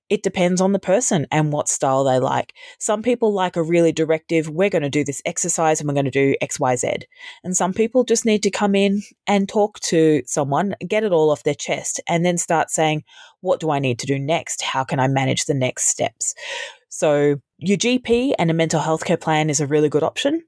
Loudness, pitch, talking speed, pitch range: -20 LUFS, 170 Hz, 230 wpm, 150-205 Hz